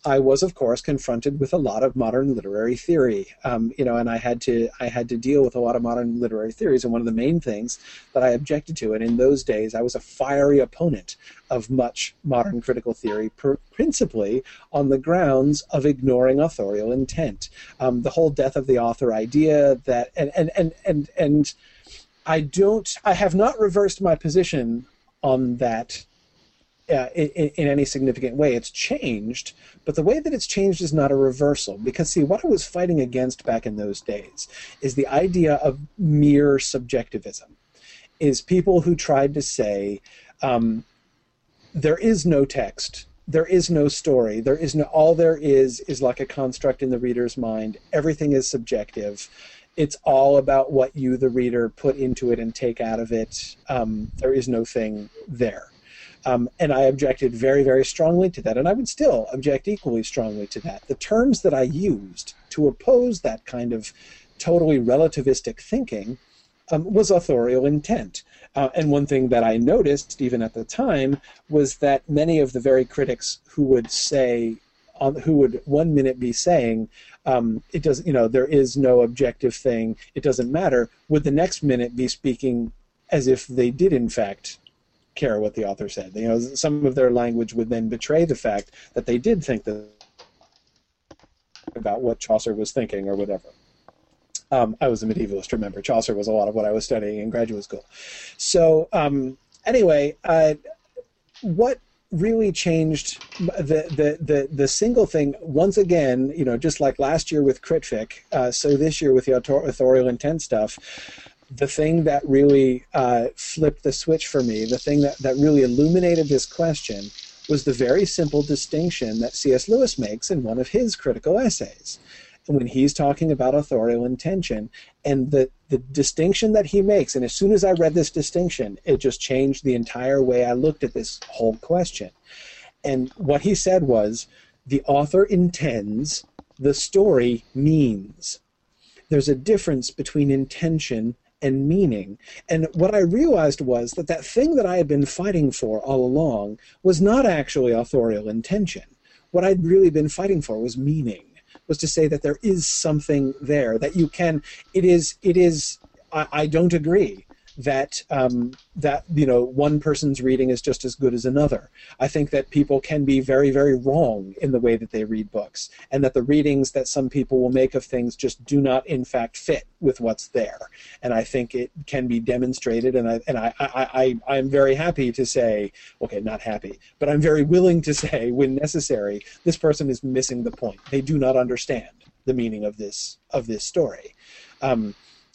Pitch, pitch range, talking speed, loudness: 135 Hz, 125-155 Hz, 185 wpm, -21 LUFS